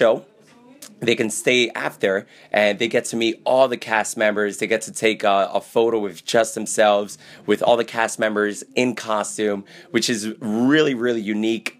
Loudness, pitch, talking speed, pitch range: -20 LUFS, 110 Hz, 185 wpm, 105-120 Hz